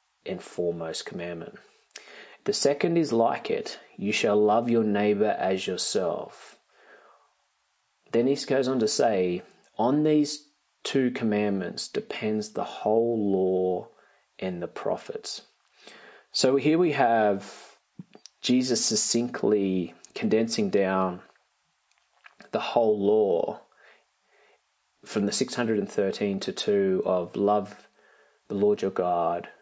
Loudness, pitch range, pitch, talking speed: -26 LUFS, 95-125 Hz, 105 Hz, 110 wpm